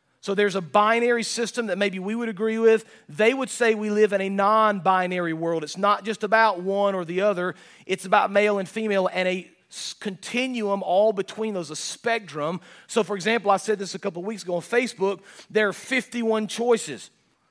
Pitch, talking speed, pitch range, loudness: 205 Hz, 200 wpm, 190-220 Hz, -24 LUFS